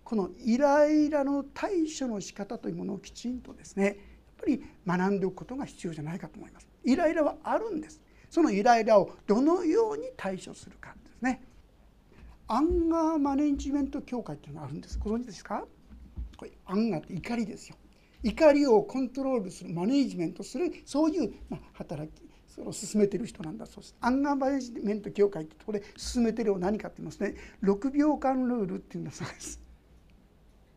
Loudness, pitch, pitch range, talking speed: -29 LUFS, 240 Hz, 195-285 Hz, 405 characters per minute